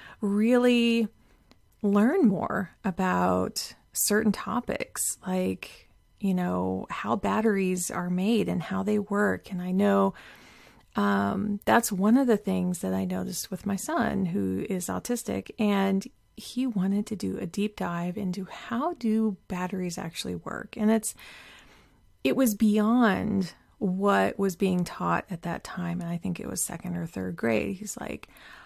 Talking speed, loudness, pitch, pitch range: 150 wpm, -27 LUFS, 195 Hz, 180-215 Hz